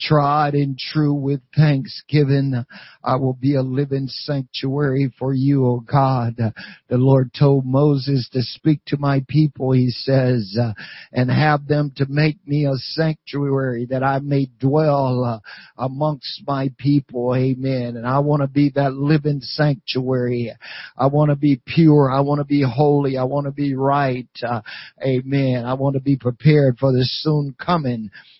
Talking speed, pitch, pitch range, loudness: 165 wpm, 135 Hz, 130-145 Hz, -19 LUFS